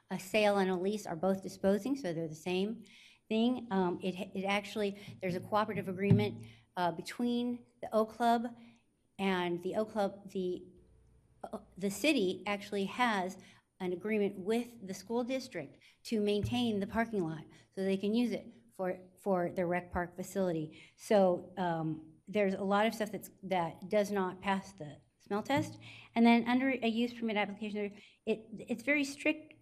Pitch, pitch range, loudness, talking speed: 200 Hz, 185-220 Hz, -34 LUFS, 170 wpm